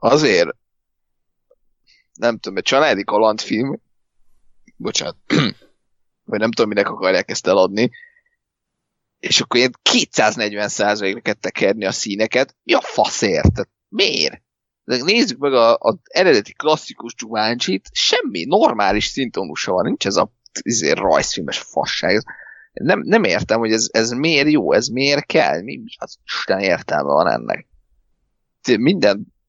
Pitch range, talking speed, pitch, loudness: 110-155 Hz, 130 wpm, 115 Hz, -17 LUFS